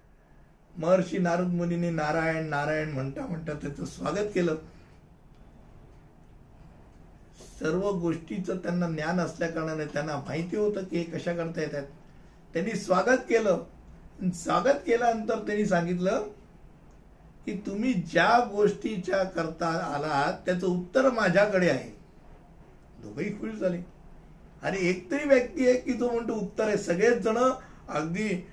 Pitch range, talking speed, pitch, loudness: 165-210 Hz, 120 wpm, 180 Hz, -28 LUFS